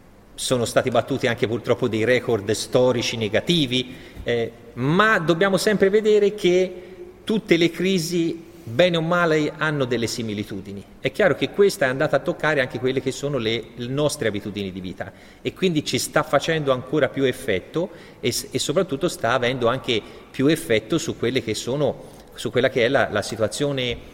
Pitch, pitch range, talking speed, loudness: 135 Hz, 115-170 Hz, 165 wpm, -22 LUFS